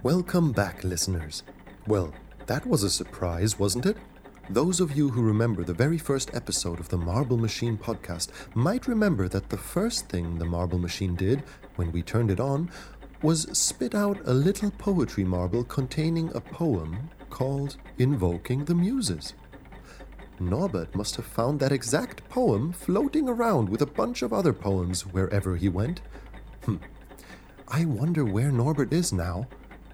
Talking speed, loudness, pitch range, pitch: 155 wpm, -27 LUFS, 95-160 Hz, 120 Hz